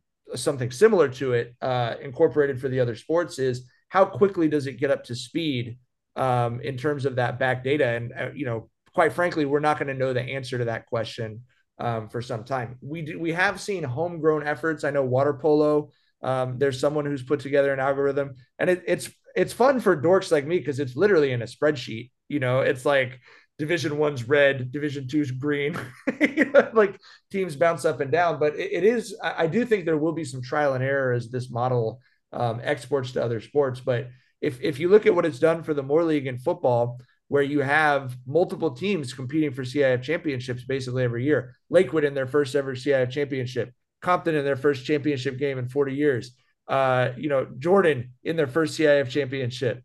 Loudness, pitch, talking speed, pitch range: -24 LUFS, 140 Hz, 205 wpm, 125-160 Hz